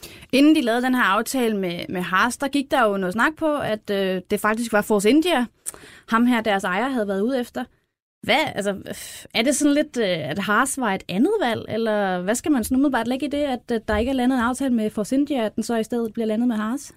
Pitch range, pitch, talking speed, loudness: 210-265 Hz, 230 Hz, 250 wpm, -21 LUFS